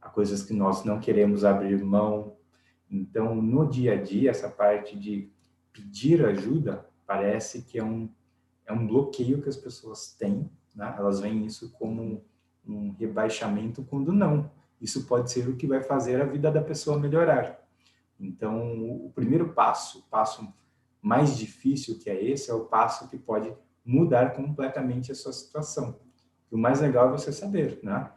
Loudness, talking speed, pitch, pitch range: -27 LUFS, 170 wpm, 115 Hz, 105-135 Hz